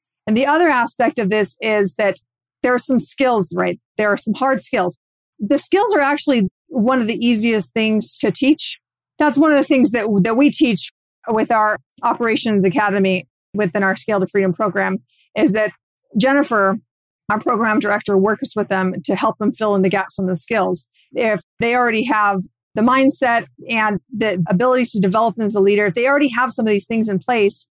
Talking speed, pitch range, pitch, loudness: 200 wpm, 195-250 Hz, 215 Hz, -17 LUFS